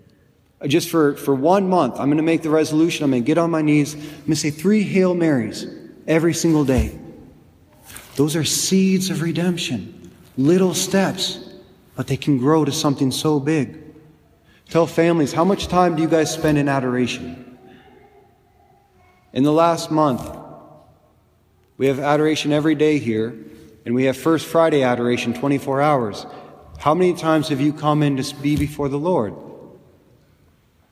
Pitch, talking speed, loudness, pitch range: 150 Hz, 165 wpm, -19 LUFS, 135-165 Hz